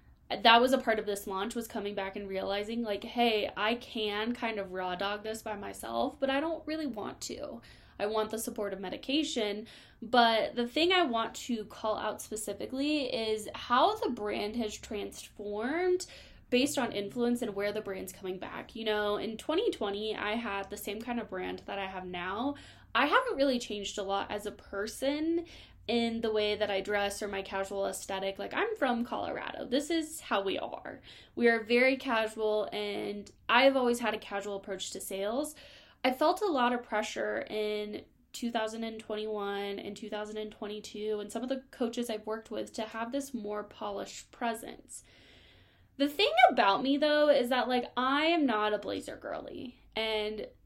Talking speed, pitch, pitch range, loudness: 180 wpm, 220 Hz, 205-250 Hz, -32 LUFS